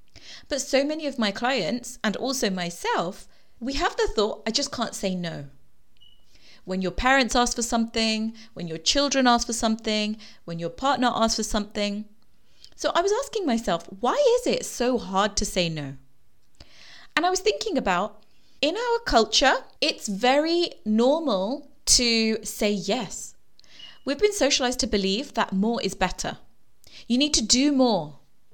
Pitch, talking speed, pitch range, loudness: 230 Hz, 160 wpm, 205-275 Hz, -24 LUFS